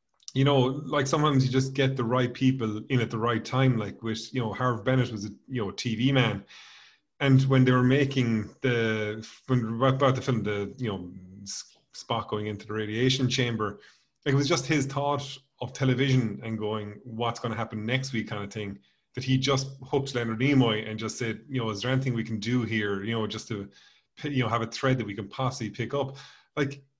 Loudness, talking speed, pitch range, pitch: -27 LUFS, 220 wpm, 110-135 Hz, 125 Hz